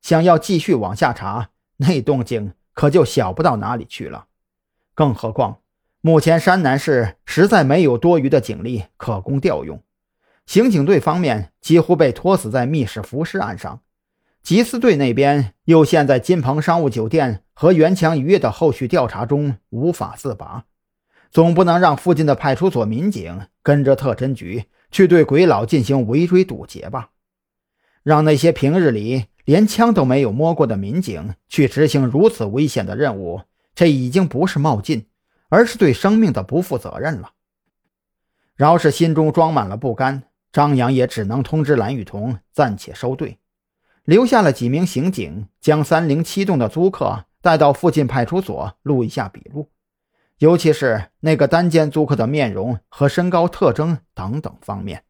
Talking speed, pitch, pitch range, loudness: 250 characters per minute, 145 Hz, 125-170 Hz, -17 LUFS